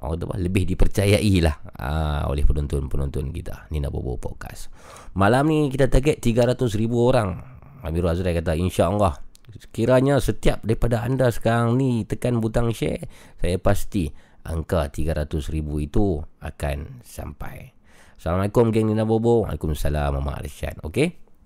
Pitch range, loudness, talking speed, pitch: 75-115 Hz, -23 LUFS, 125 wpm, 95 Hz